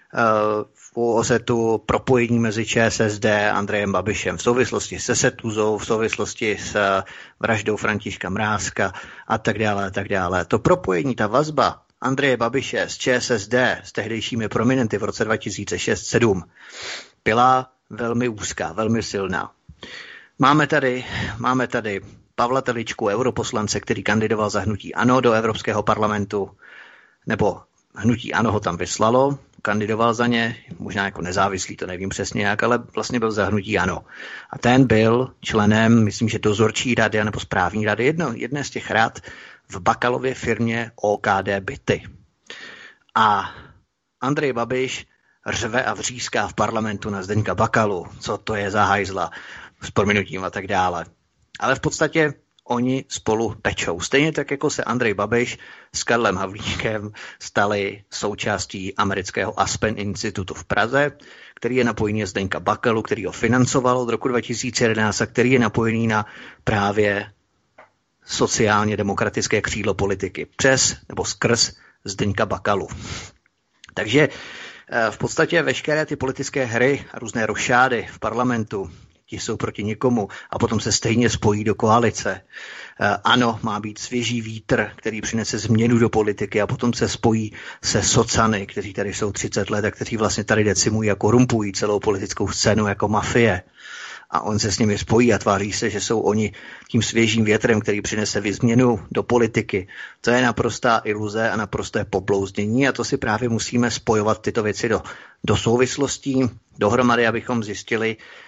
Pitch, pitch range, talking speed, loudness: 110 Hz, 105-120 Hz, 150 wpm, -21 LUFS